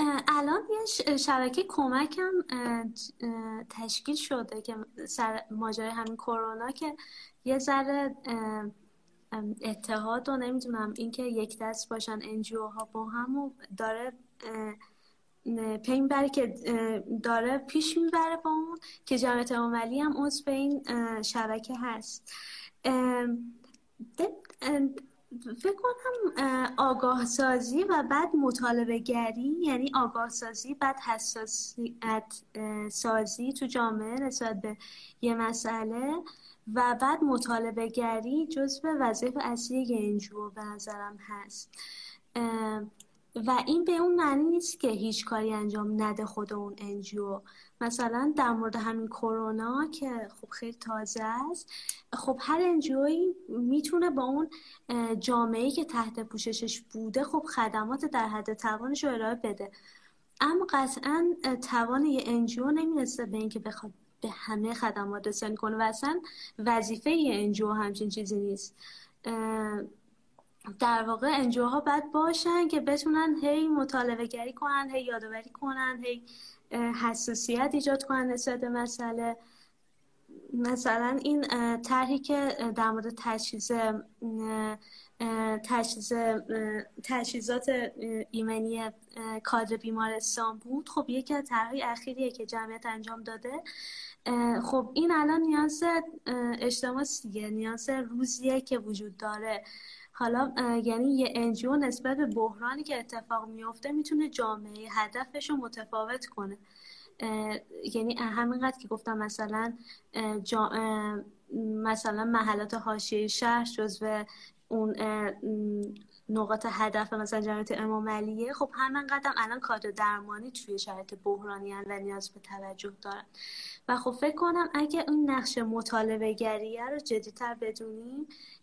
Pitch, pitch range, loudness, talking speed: 235 Hz, 220-270 Hz, -31 LUFS, 120 wpm